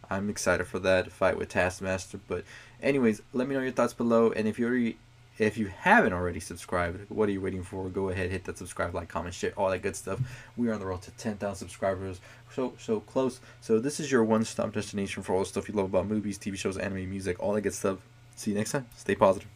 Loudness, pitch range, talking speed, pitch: -30 LUFS, 95-115 Hz, 245 wpm, 105 Hz